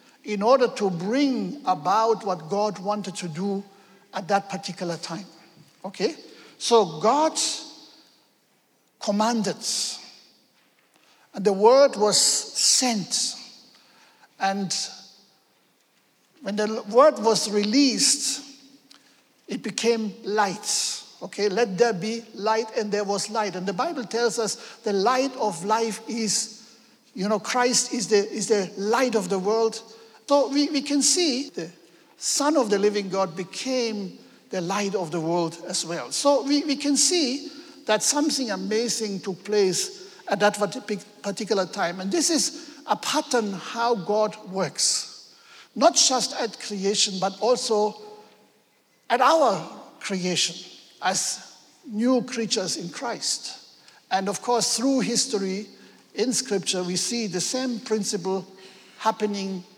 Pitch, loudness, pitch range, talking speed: 215 Hz, -24 LUFS, 195-245 Hz, 130 wpm